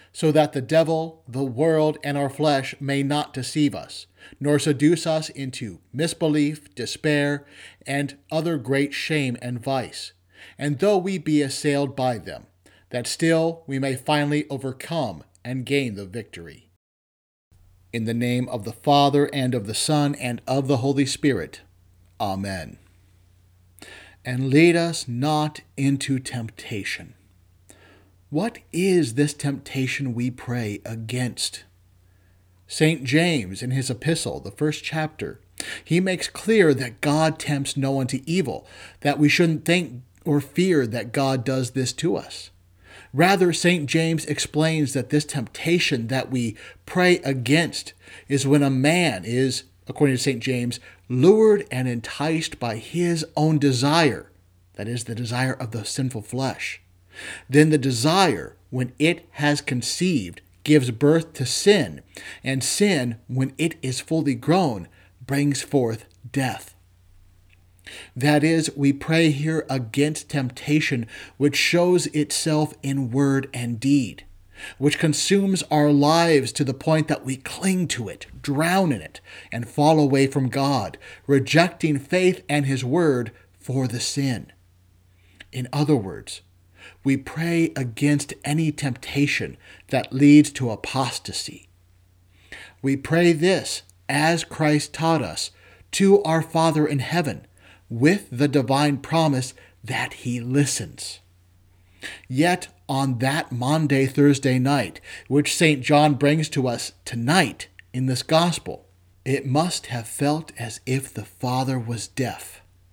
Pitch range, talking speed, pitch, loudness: 115-150 Hz, 135 wpm, 135 Hz, -22 LUFS